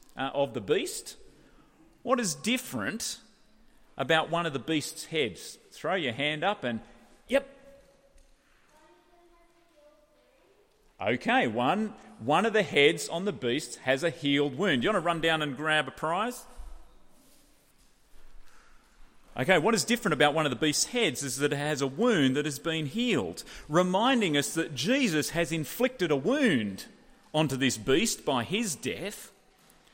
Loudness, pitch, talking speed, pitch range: -28 LUFS, 170 Hz, 150 wpm, 150-245 Hz